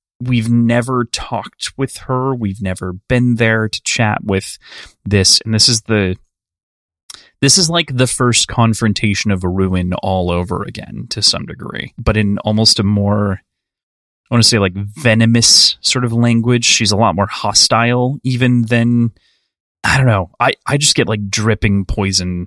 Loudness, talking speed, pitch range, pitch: -13 LUFS, 170 wpm, 100-120 Hz, 110 Hz